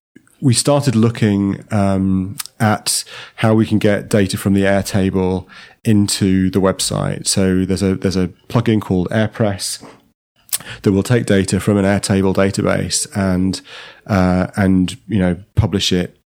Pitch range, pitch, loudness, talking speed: 95-110 Hz, 100 Hz, -16 LUFS, 145 wpm